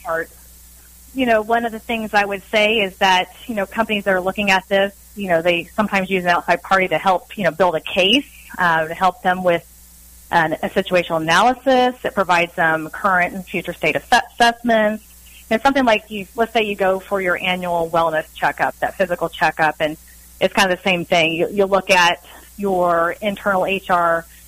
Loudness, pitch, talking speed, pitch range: -18 LUFS, 185 Hz, 200 wpm, 170-205 Hz